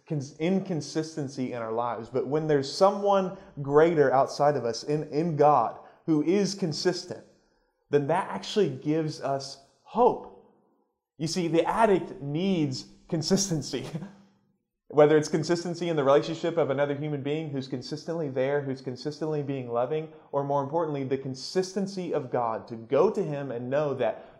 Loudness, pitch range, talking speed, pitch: -27 LUFS, 135-170 Hz, 150 wpm, 150 Hz